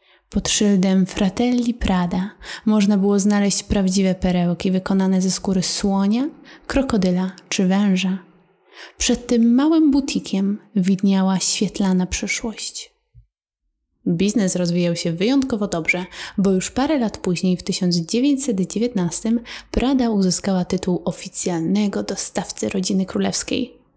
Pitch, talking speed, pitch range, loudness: 195 Hz, 105 wpm, 185-230 Hz, -20 LUFS